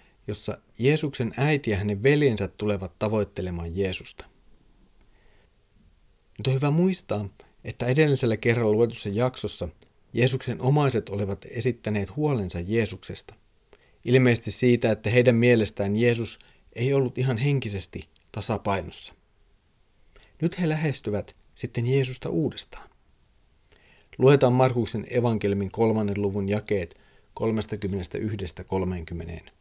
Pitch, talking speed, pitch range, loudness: 110 Hz, 95 wpm, 100-125 Hz, -25 LUFS